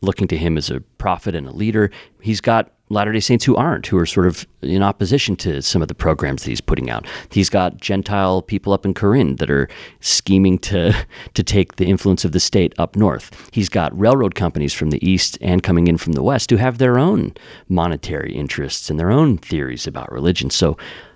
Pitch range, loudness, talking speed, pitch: 85-105 Hz, -18 LUFS, 215 wpm, 95 Hz